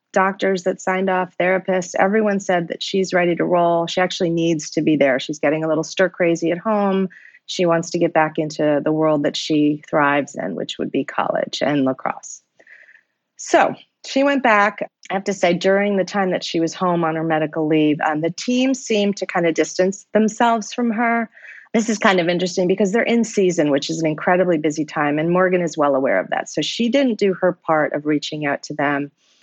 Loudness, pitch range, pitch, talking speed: -19 LUFS, 155-195 Hz, 180 Hz, 220 wpm